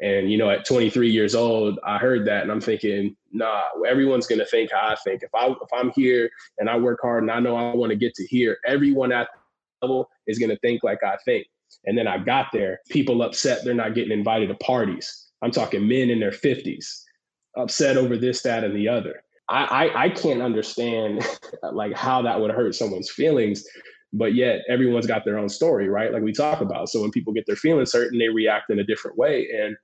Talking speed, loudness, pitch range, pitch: 230 wpm, -22 LUFS, 110-130 Hz, 120 Hz